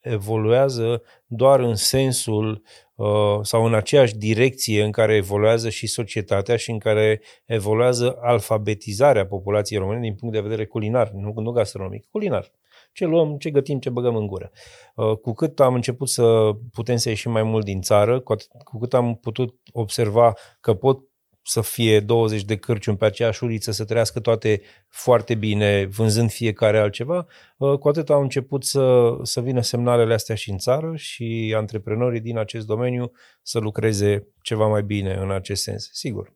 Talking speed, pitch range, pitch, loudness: 170 wpm, 110-125 Hz, 115 Hz, -21 LUFS